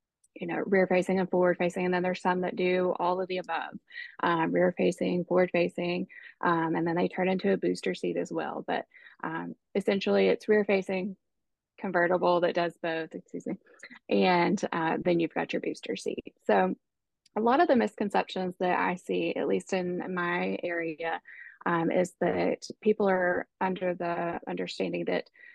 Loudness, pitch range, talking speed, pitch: -29 LUFS, 175-190 Hz, 180 wpm, 180 Hz